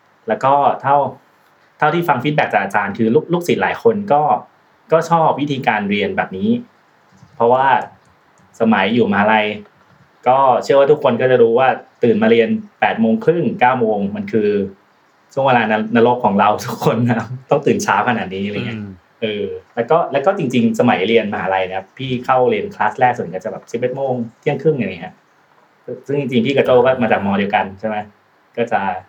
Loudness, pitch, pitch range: -16 LUFS, 125 Hz, 105-160 Hz